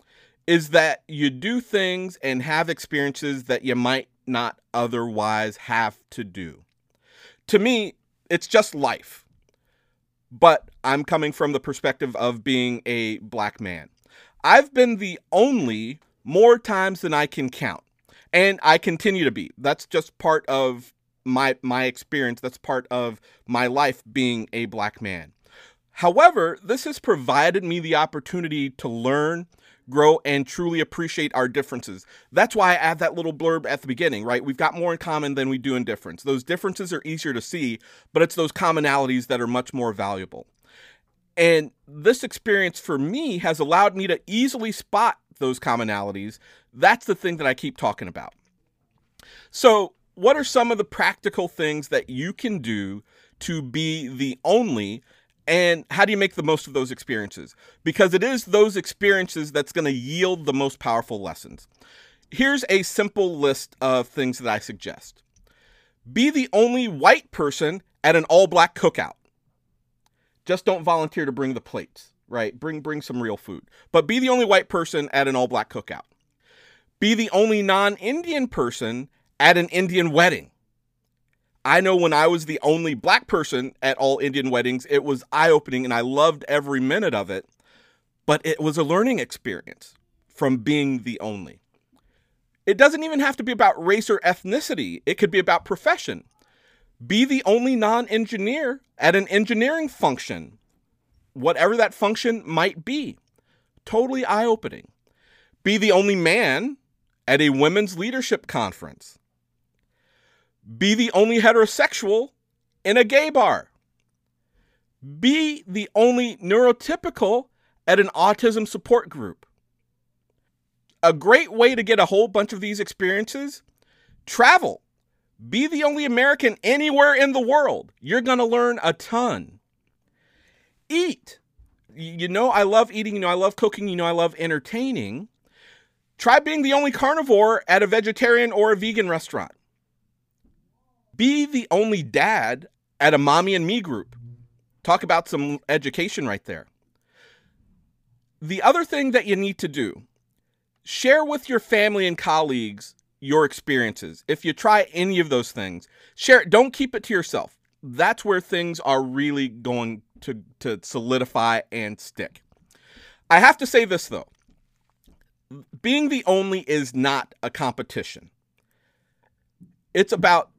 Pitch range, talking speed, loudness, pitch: 130-220 Hz, 155 wpm, -21 LUFS, 170 Hz